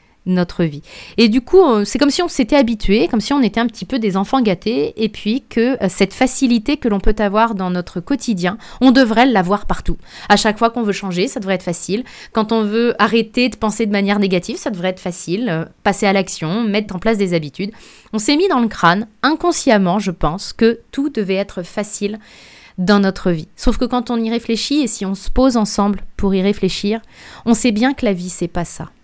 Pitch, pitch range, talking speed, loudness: 215 Hz, 195-240 Hz, 225 wpm, -16 LUFS